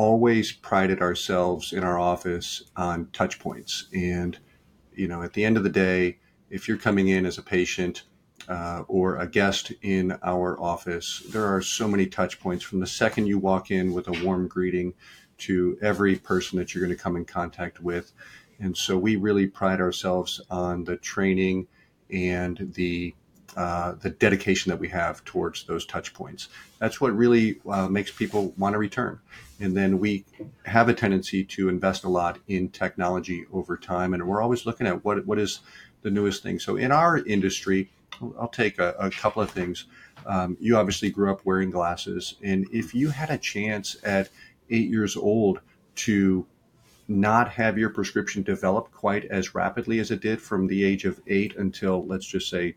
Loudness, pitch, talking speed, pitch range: -26 LUFS, 95 Hz, 185 wpm, 90-100 Hz